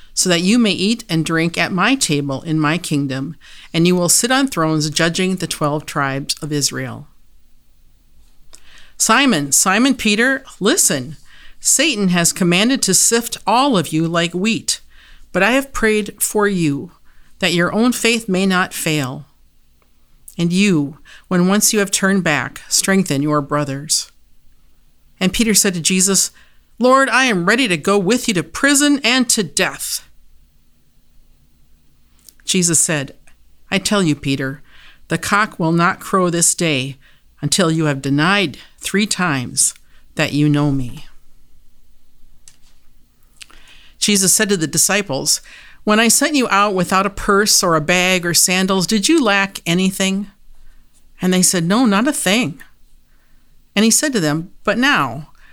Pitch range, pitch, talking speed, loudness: 155-210 Hz, 185 Hz, 150 wpm, -15 LUFS